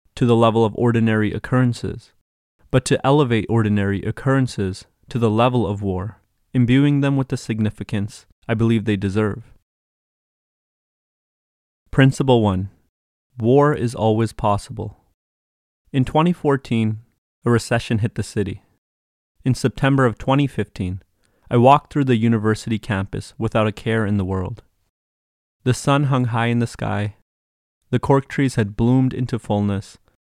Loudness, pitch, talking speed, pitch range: -20 LUFS, 110 Hz, 135 wpm, 100-125 Hz